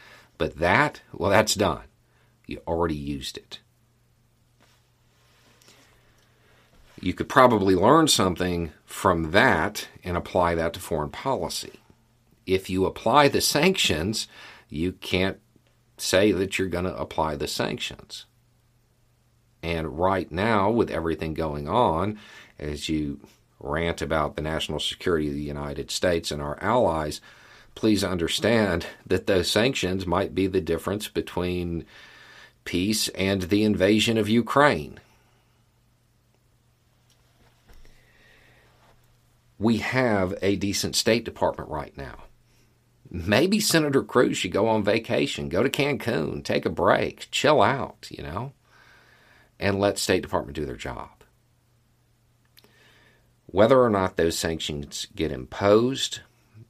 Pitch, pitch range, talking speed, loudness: 100 Hz, 85-120 Hz, 120 wpm, -24 LUFS